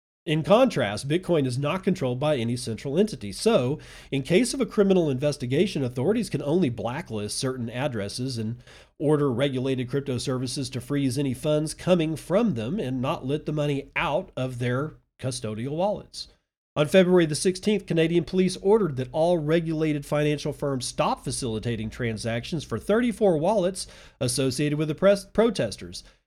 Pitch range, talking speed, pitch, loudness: 130-175 Hz, 155 wpm, 145 Hz, -25 LUFS